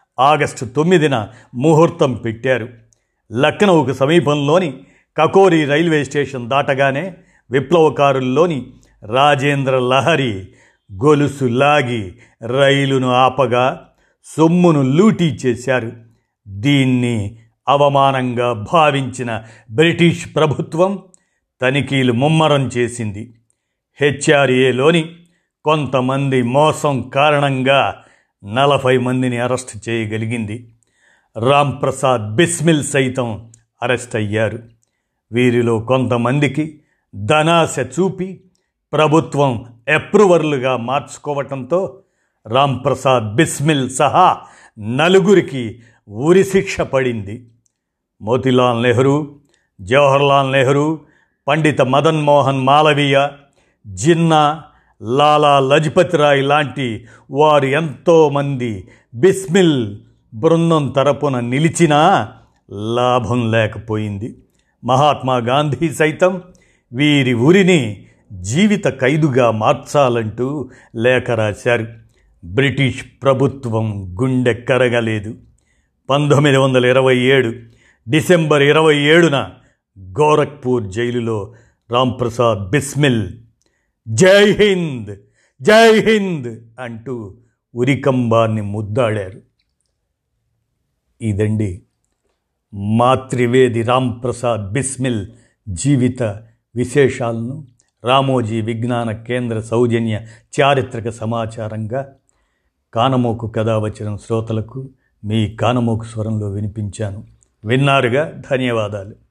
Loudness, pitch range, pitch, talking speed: -15 LUFS, 115-145 Hz, 130 Hz, 70 wpm